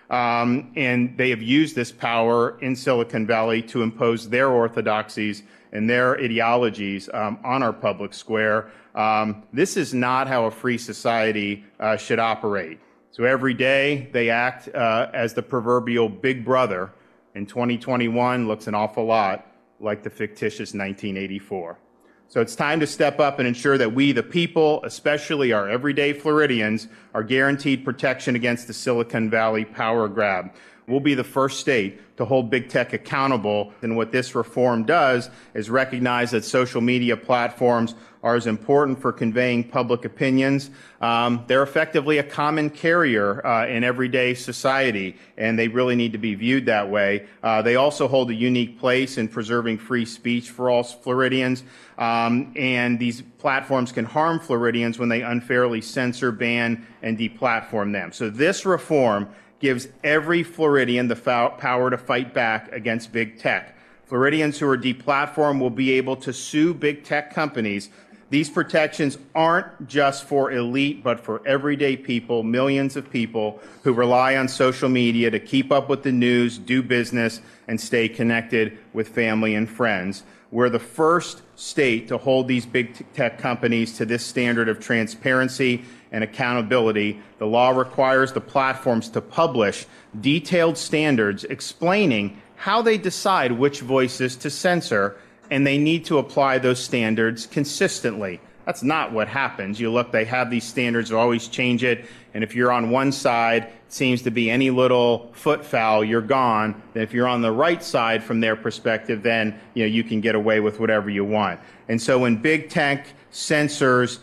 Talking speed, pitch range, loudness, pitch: 165 wpm, 115-135 Hz, -22 LUFS, 120 Hz